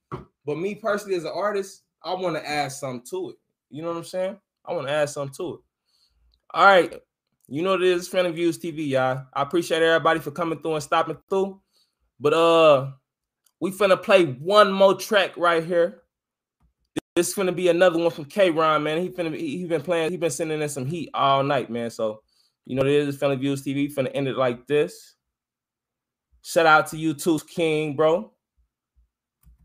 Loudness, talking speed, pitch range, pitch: -22 LUFS, 205 wpm, 145-180 Hz, 165 Hz